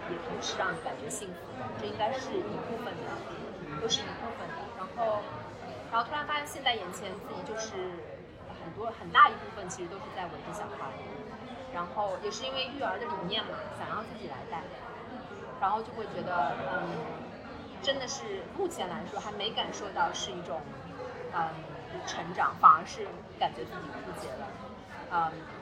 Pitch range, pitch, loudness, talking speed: 205-265 Hz, 230 Hz, -33 LUFS, 255 characters per minute